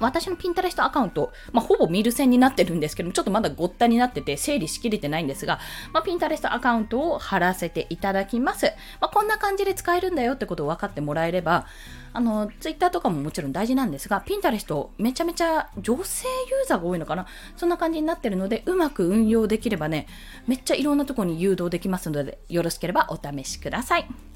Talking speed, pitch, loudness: 510 characters per minute, 230 Hz, -24 LUFS